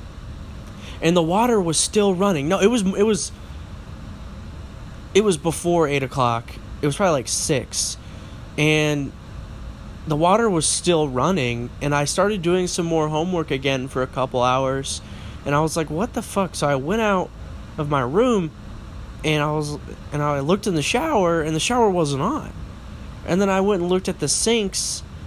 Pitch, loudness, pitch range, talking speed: 160 Hz, -21 LUFS, 140-190 Hz, 180 wpm